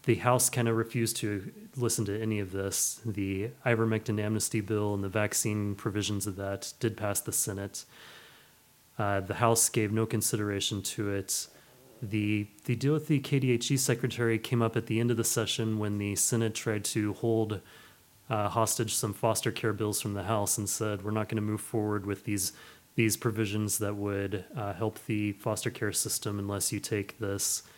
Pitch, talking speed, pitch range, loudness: 110 Hz, 190 wpm, 105-115 Hz, -30 LUFS